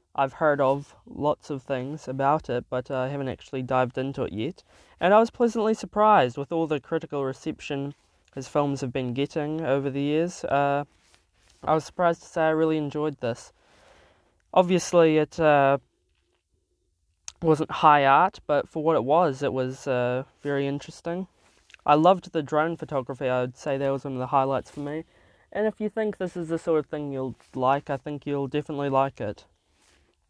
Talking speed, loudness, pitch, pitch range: 190 wpm, -25 LUFS, 145 Hz, 135-160 Hz